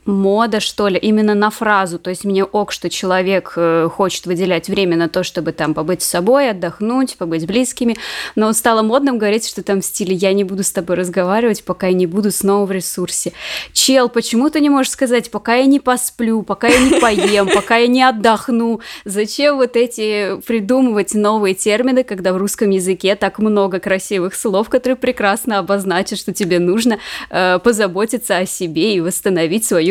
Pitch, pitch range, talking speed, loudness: 205 Hz, 185-235 Hz, 185 wpm, -15 LUFS